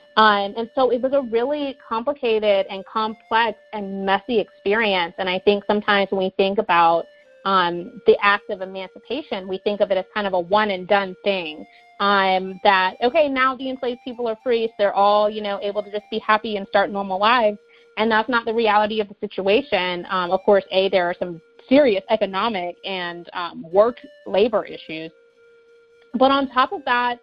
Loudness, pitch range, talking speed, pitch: -20 LUFS, 195-235 Hz, 195 wpm, 210 Hz